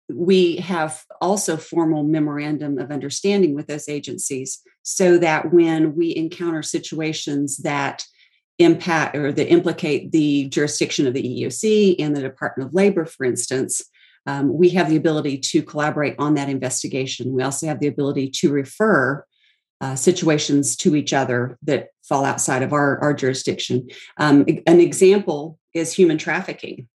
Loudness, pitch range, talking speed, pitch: -19 LUFS, 140-170 Hz, 150 wpm, 150 Hz